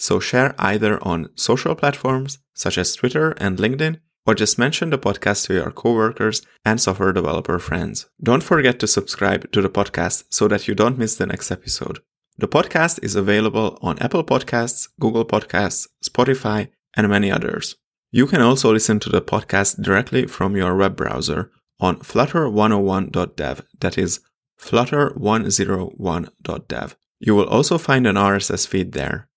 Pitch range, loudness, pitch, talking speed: 100-125 Hz, -19 LUFS, 110 Hz, 155 wpm